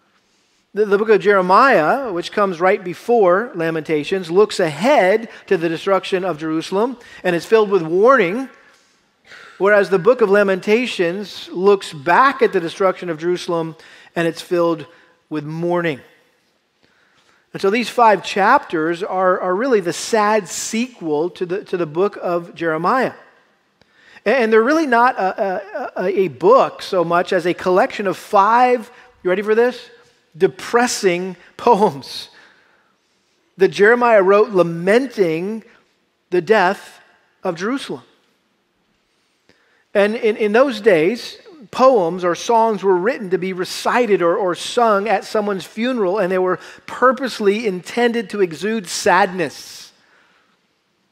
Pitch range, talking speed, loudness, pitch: 175-225 Hz, 130 wpm, -17 LUFS, 195 Hz